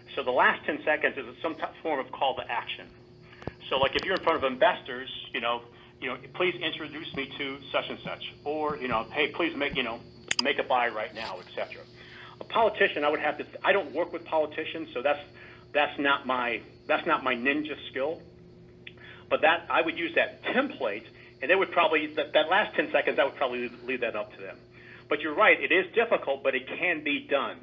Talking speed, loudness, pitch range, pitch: 225 wpm, -28 LUFS, 120-155 Hz, 140 Hz